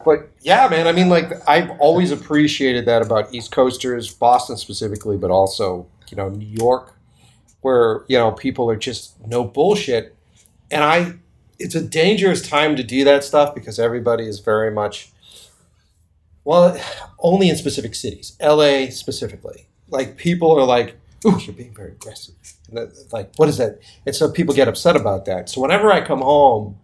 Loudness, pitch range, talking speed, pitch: -17 LUFS, 110-150 Hz, 170 wpm, 125 Hz